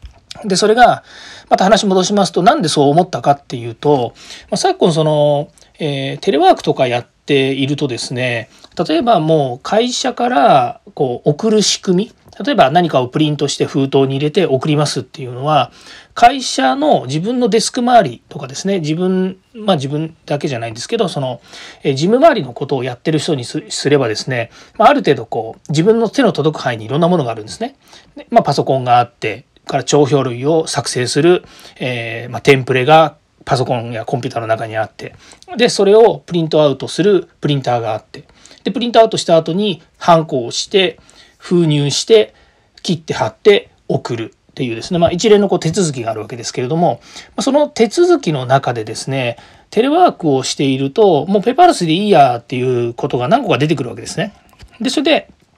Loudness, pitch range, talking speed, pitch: -14 LUFS, 130-200 Hz, 390 characters per minute, 155 Hz